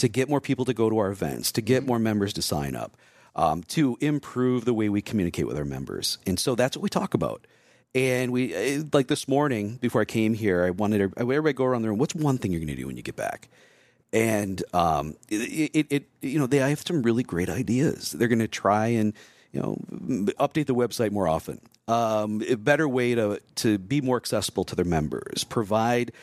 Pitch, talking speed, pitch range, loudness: 120 Hz, 225 wpm, 105-135 Hz, -26 LUFS